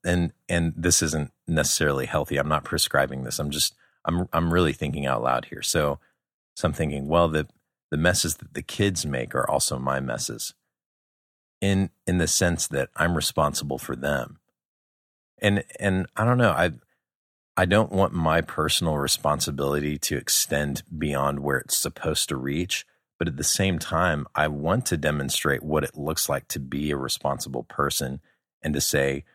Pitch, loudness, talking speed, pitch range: 75 Hz, -25 LUFS, 175 wpm, 70-85 Hz